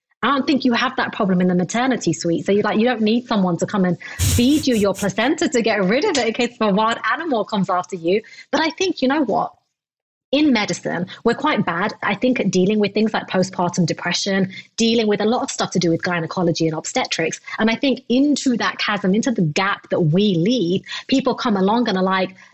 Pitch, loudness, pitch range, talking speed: 210 Hz, -19 LUFS, 185-245 Hz, 235 wpm